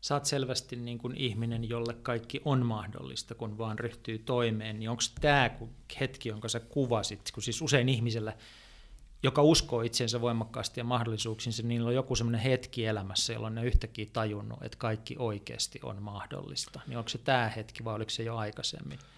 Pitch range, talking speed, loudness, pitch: 110-125 Hz, 175 wpm, -32 LUFS, 115 Hz